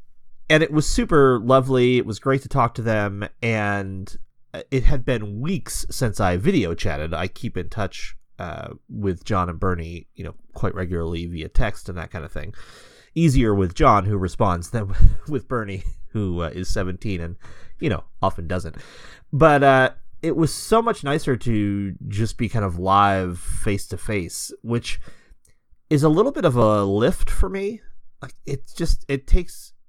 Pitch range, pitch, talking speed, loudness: 90-130 Hz, 105 Hz, 180 wpm, -22 LUFS